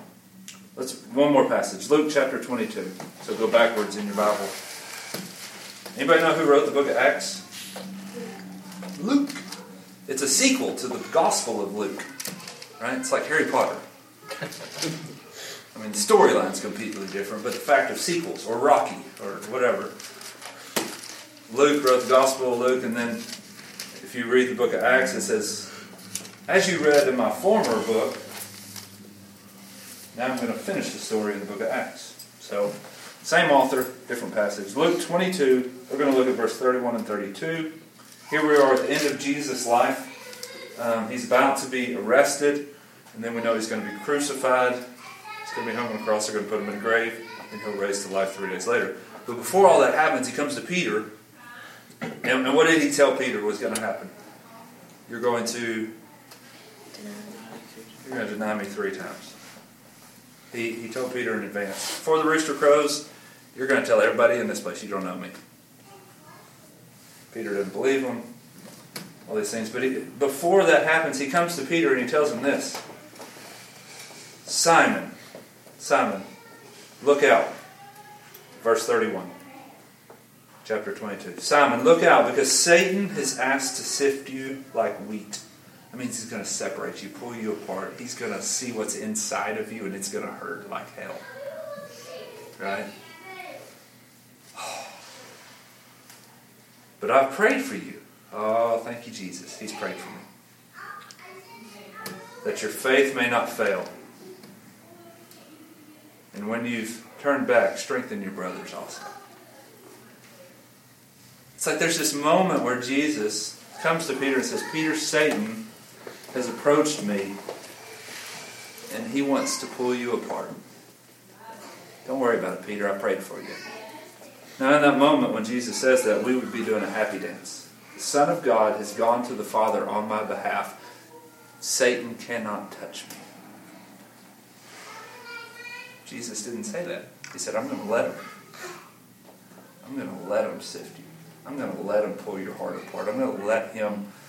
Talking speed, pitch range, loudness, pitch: 165 wpm, 105-155 Hz, -24 LUFS, 130 Hz